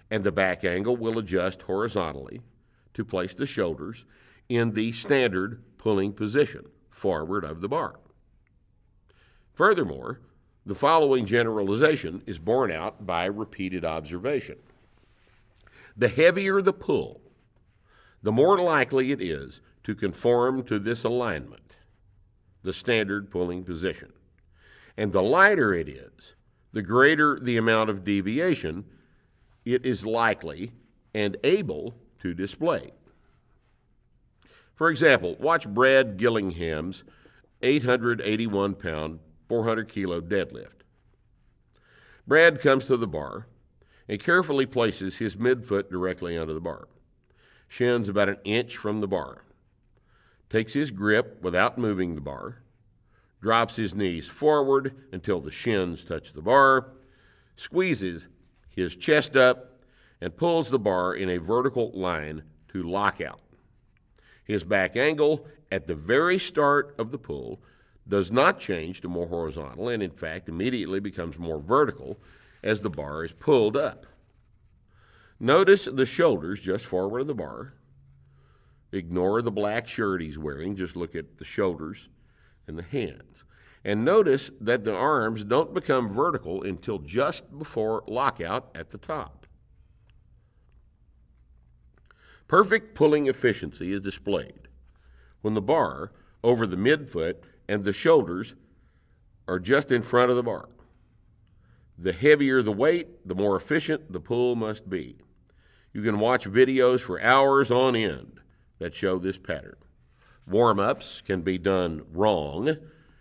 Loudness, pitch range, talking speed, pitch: -25 LUFS, 95-125 Hz, 130 wpm, 105 Hz